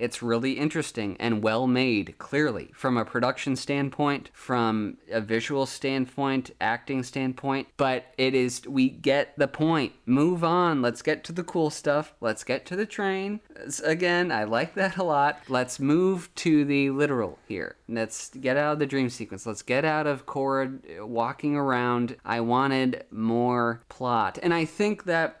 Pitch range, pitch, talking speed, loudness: 120-155 Hz, 135 Hz, 170 wpm, -26 LUFS